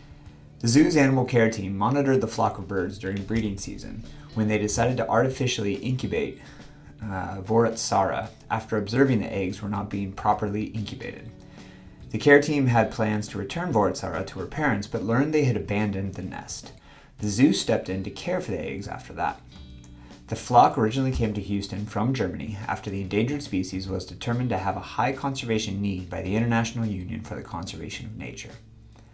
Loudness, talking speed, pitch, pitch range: -26 LUFS, 180 wpm, 105 Hz, 100-115 Hz